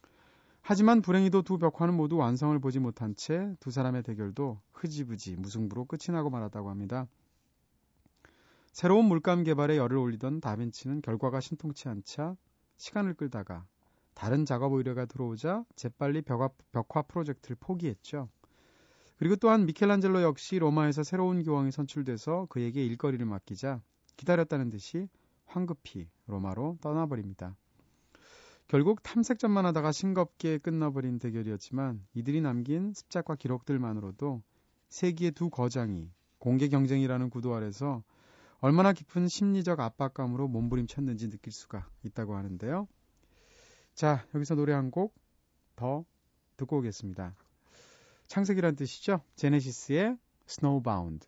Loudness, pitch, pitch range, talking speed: -31 LUFS, 140 Hz, 115-165 Hz, 325 characters per minute